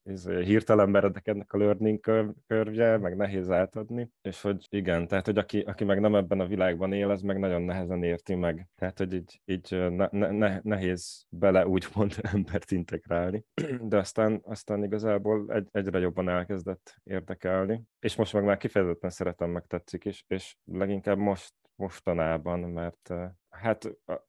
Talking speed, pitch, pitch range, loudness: 165 wpm, 100 Hz, 90-105 Hz, -29 LUFS